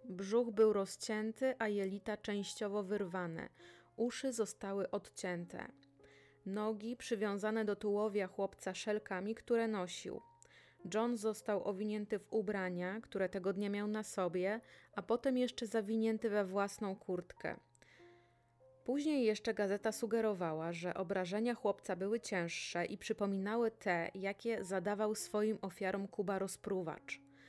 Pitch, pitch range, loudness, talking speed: 205 Hz, 190-220 Hz, -39 LUFS, 120 wpm